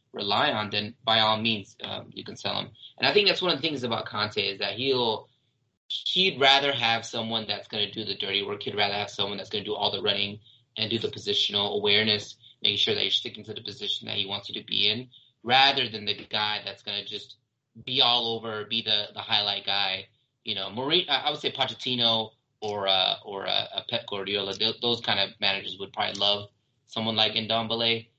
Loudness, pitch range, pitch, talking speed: -25 LUFS, 105-120 Hz, 110 Hz, 225 wpm